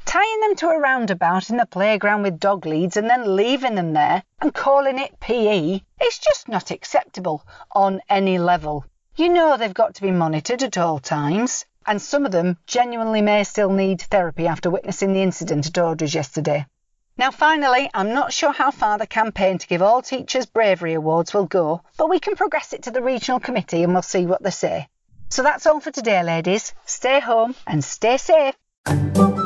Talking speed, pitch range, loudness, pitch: 195 wpm, 175-260 Hz, -20 LUFS, 205 Hz